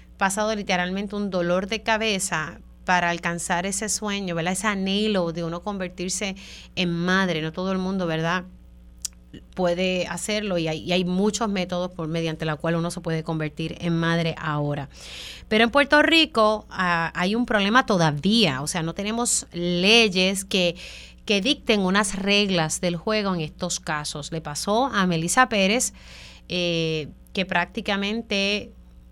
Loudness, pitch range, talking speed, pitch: -23 LUFS, 165-205 Hz, 155 wpm, 180 Hz